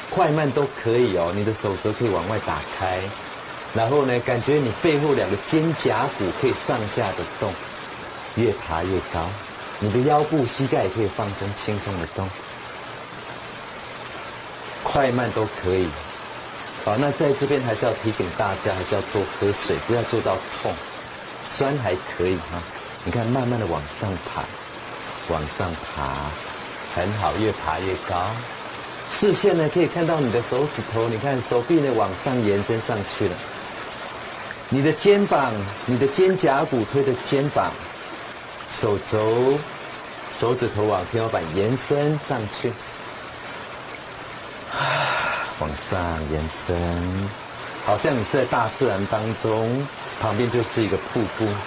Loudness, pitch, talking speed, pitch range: -24 LUFS, 115 Hz, 205 characters per minute, 100-140 Hz